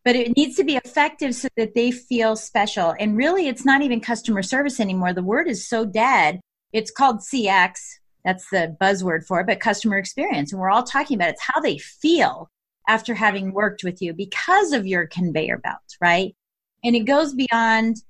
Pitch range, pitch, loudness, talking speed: 195-265 Hz, 225 Hz, -20 LUFS, 195 wpm